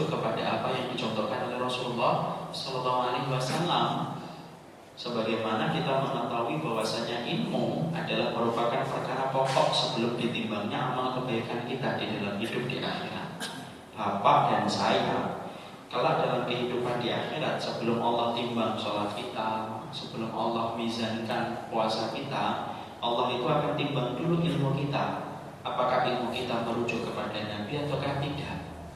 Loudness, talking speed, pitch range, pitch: -30 LUFS, 125 wpm, 115-130 Hz, 120 Hz